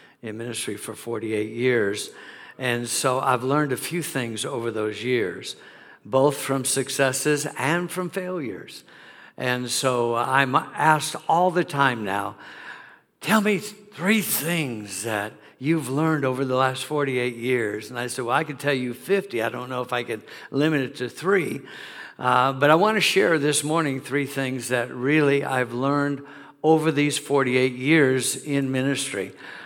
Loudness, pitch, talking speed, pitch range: -23 LUFS, 135 Hz, 160 wpm, 125-150 Hz